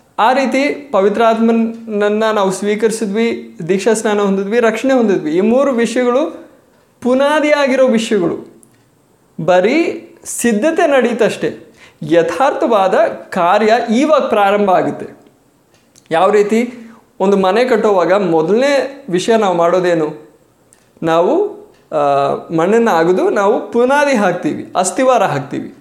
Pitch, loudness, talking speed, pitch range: 225 Hz, -13 LUFS, 95 wpm, 190-255 Hz